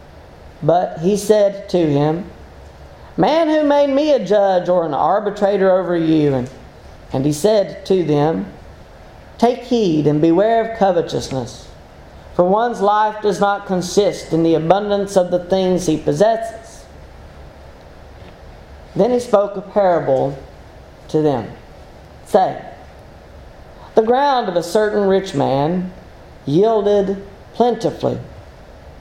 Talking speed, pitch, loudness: 120 wpm, 180 Hz, -16 LUFS